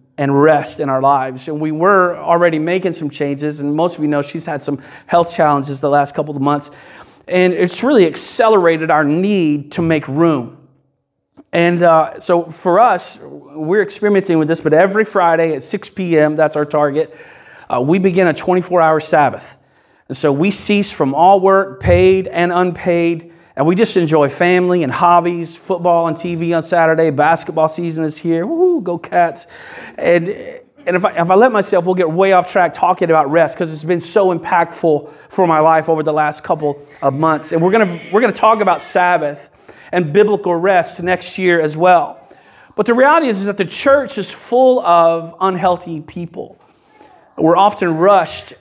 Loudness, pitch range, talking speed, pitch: -14 LUFS, 155-185 Hz, 185 wpm, 170 Hz